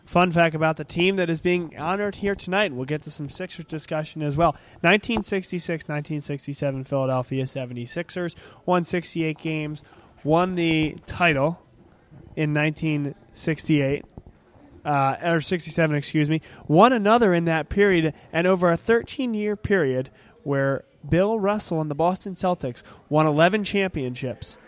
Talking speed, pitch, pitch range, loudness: 140 wpm, 160 Hz, 145-180 Hz, -23 LUFS